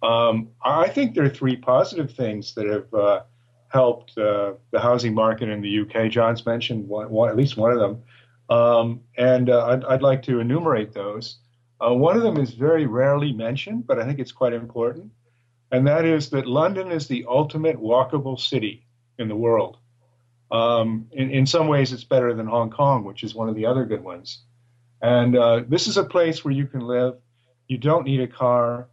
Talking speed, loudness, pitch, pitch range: 200 wpm, -21 LUFS, 120 Hz, 115-135 Hz